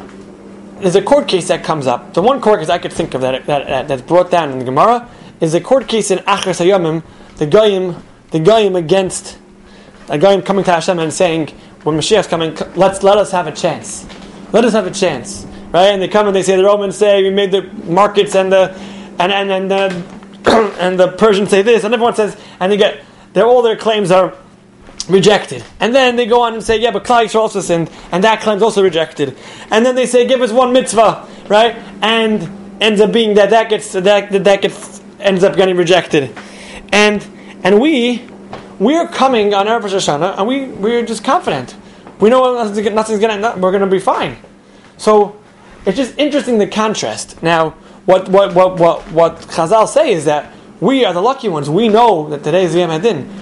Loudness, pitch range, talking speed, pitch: -13 LUFS, 180-220 Hz, 210 wpm, 195 Hz